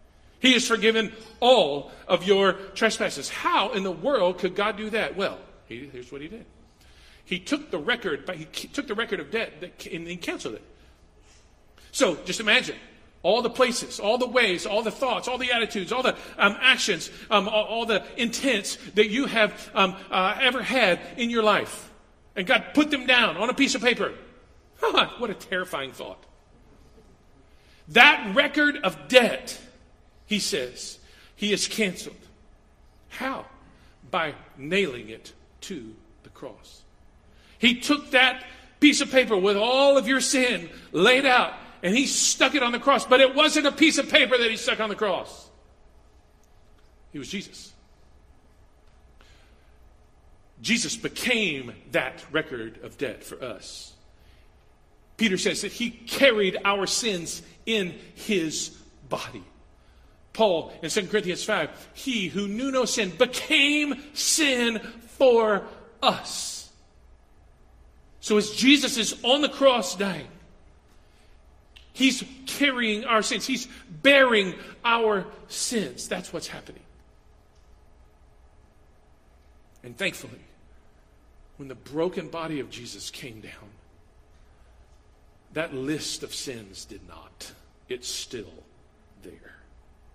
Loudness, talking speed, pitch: -23 LUFS, 140 wpm, 205 Hz